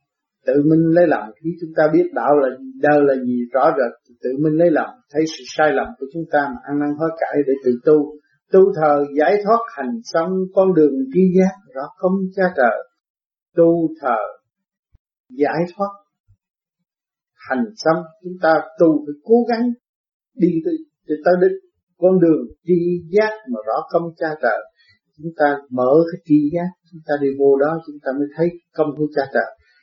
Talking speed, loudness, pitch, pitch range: 185 wpm, -18 LUFS, 165 Hz, 145-185 Hz